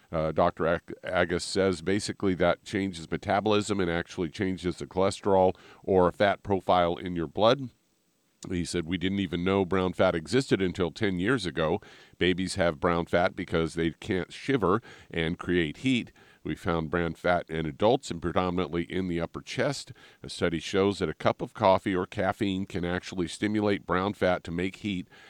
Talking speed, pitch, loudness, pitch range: 175 wpm, 90 Hz, -28 LUFS, 85-95 Hz